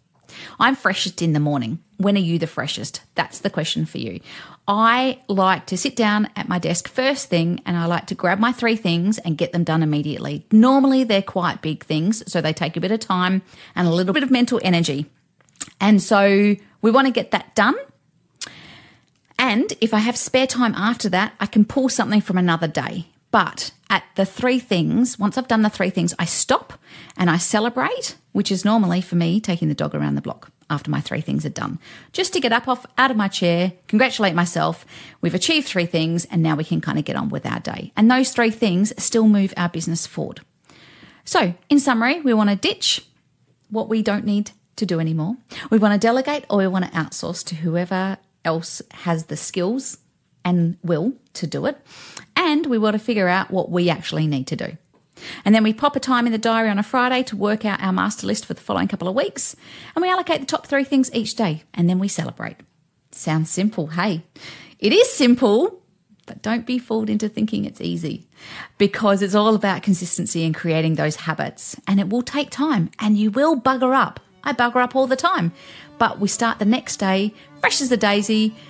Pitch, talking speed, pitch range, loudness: 205 Hz, 210 wpm, 175-235 Hz, -20 LUFS